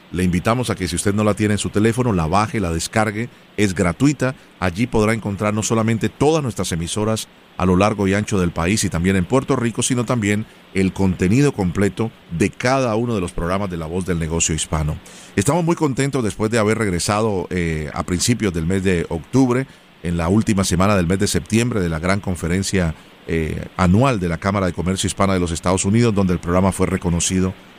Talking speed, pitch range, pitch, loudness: 210 wpm, 90-110 Hz, 100 Hz, -19 LUFS